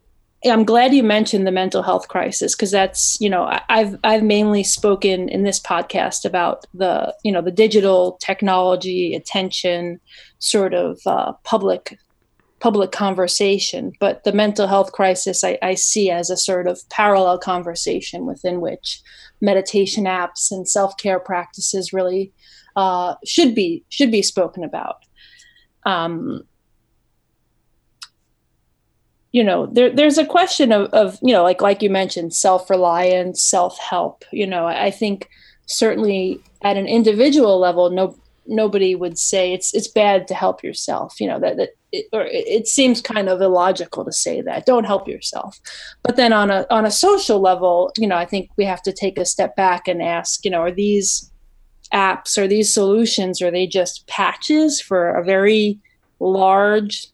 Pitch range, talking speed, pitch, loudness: 185-215 Hz, 165 wpm, 195 Hz, -17 LUFS